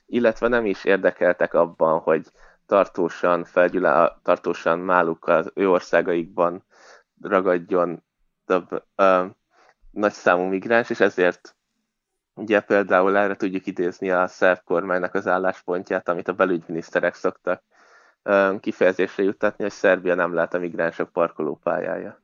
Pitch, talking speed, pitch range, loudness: 95 Hz, 120 wpm, 90-100 Hz, -21 LUFS